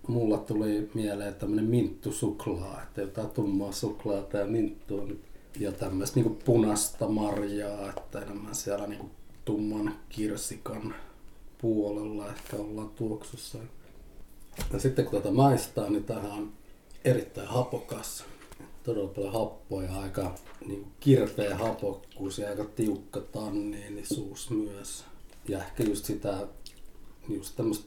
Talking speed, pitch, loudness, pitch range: 115 wpm, 105 Hz, -32 LUFS, 100-110 Hz